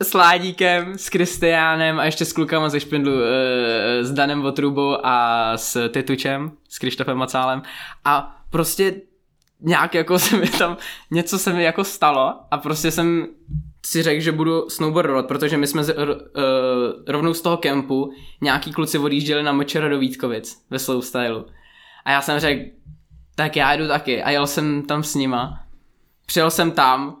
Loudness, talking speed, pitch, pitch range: -20 LUFS, 170 wpm, 145 Hz, 135-165 Hz